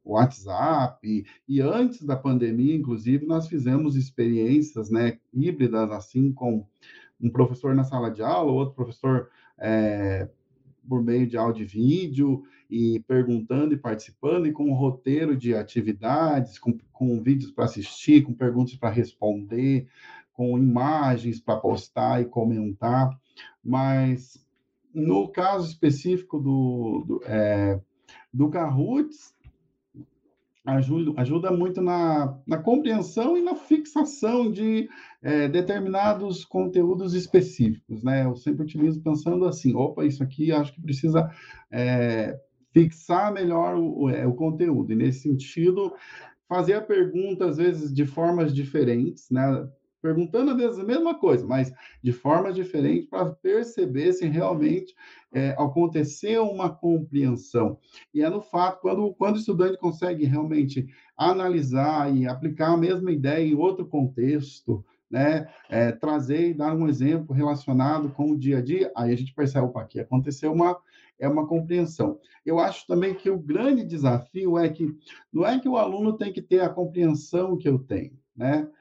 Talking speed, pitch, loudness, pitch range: 145 wpm, 145 Hz, -24 LUFS, 125-180 Hz